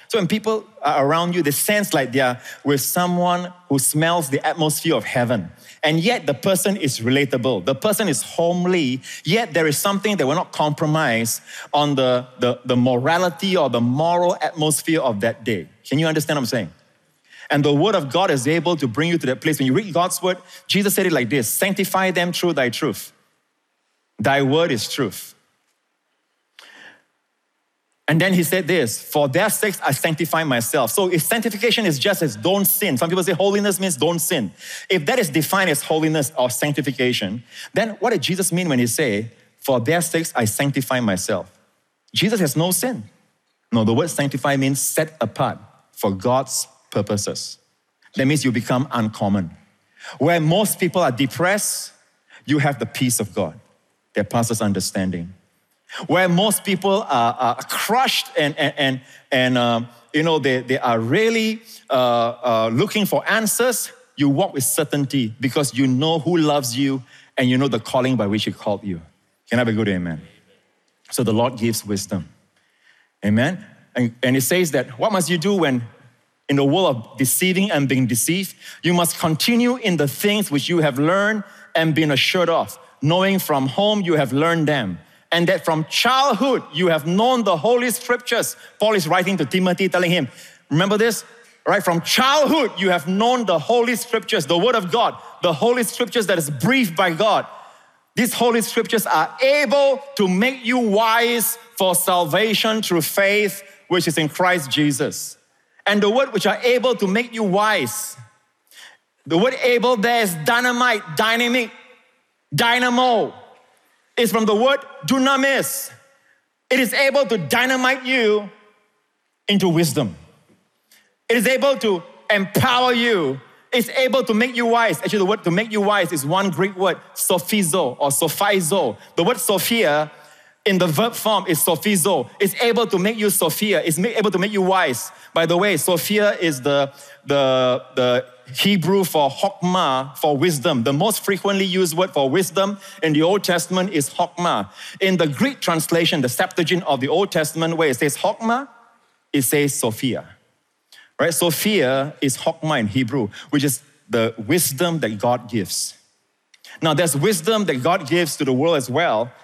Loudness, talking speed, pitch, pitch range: -19 LUFS, 175 wpm, 175 Hz, 140-205 Hz